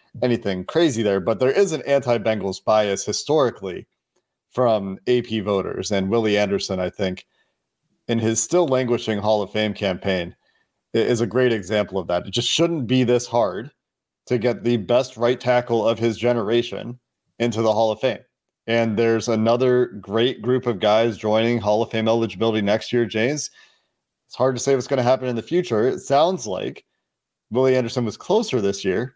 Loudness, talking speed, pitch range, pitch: -21 LUFS, 180 wpm, 105-125 Hz, 115 Hz